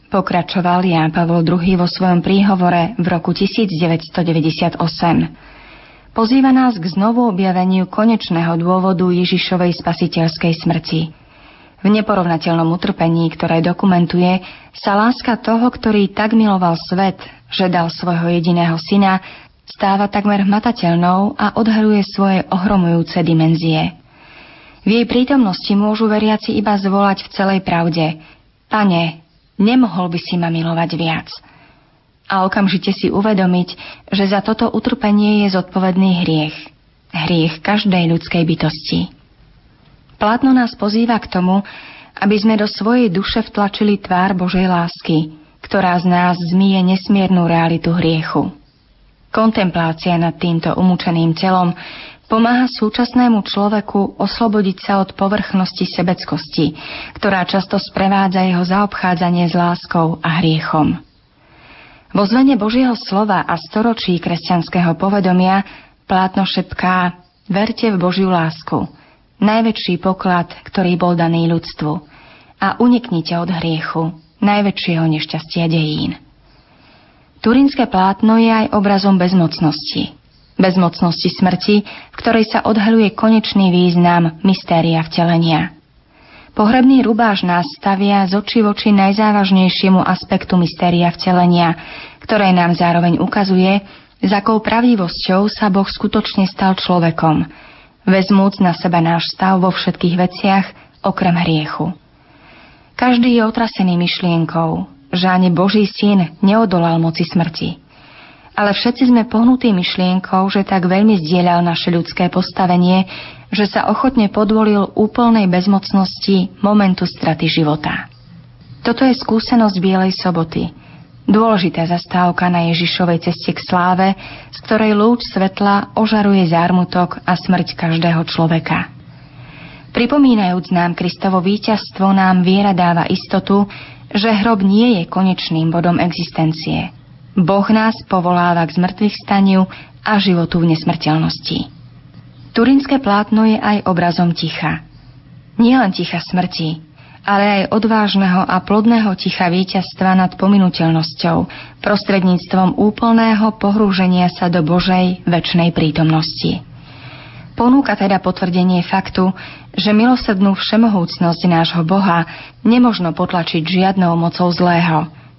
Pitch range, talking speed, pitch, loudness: 170-205 Hz, 115 wpm, 185 Hz, -14 LUFS